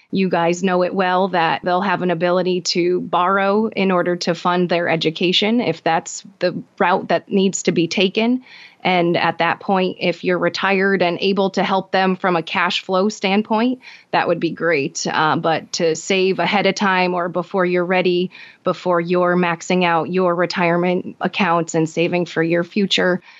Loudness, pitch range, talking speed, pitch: -18 LUFS, 175-195 Hz, 180 wpm, 180 Hz